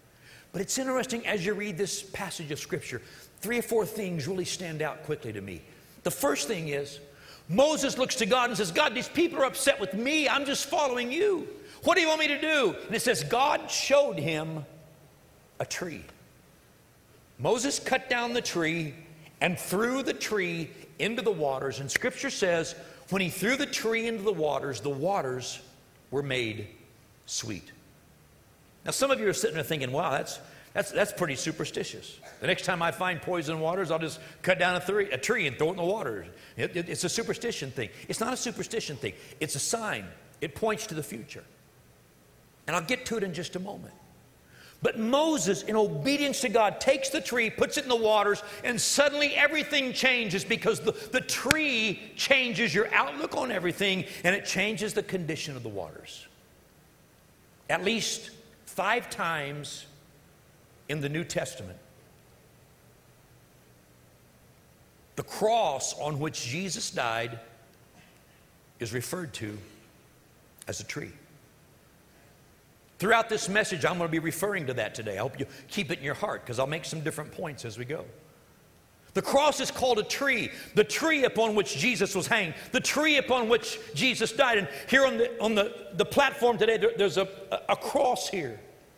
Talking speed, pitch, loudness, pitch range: 180 wpm, 195 Hz, -28 LUFS, 150-235 Hz